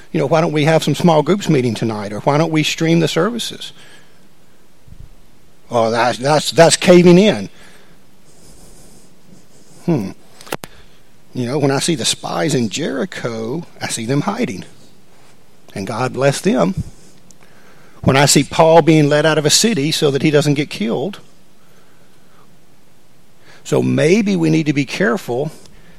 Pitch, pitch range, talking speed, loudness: 155 Hz, 140-175 Hz, 150 wpm, -15 LUFS